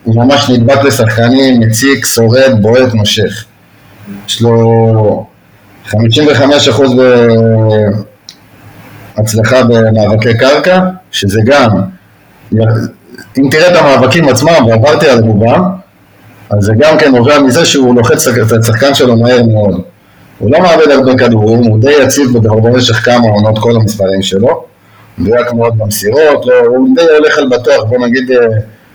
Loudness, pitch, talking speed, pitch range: -7 LUFS, 115 Hz, 130 wpm, 110-135 Hz